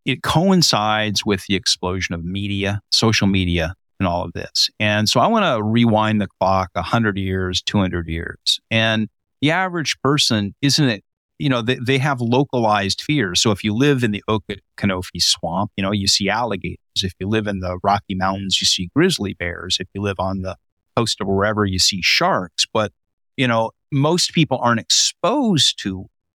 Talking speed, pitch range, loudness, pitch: 185 wpm, 95-120 Hz, -18 LUFS, 105 Hz